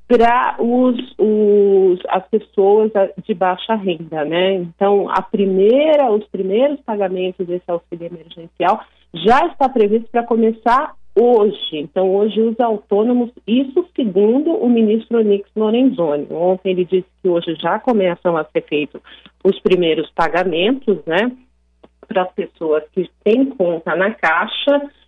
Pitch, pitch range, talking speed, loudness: 200 Hz, 180-230 Hz, 130 wpm, -16 LUFS